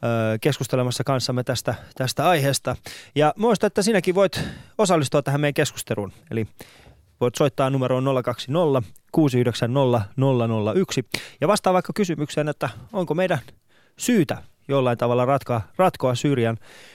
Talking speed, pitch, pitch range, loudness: 120 wpm, 135 Hz, 120-155 Hz, -22 LUFS